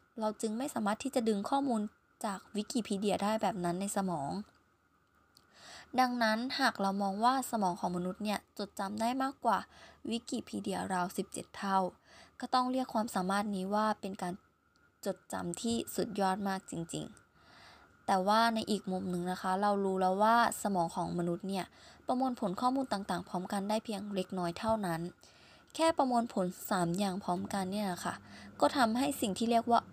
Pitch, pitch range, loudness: 200 Hz, 185-230 Hz, -34 LUFS